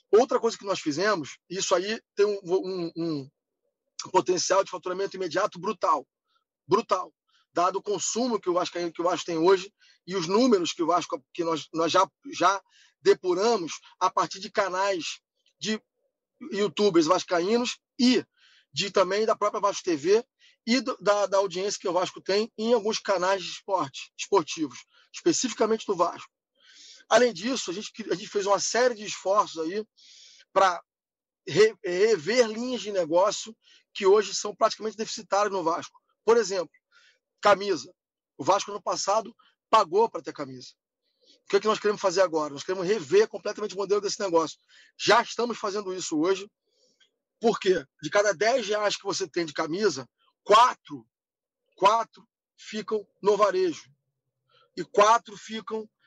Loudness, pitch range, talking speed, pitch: -26 LUFS, 190-250 Hz, 155 wpm, 210 Hz